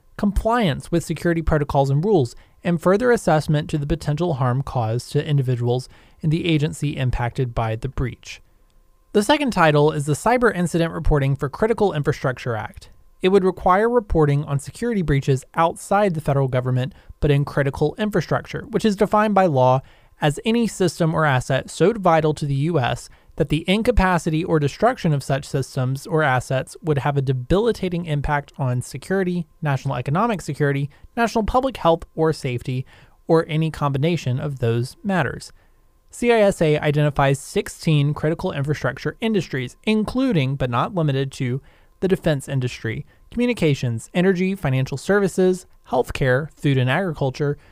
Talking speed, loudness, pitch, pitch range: 150 wpm, -21 LUFS, 150 Hz, 135-180 Hz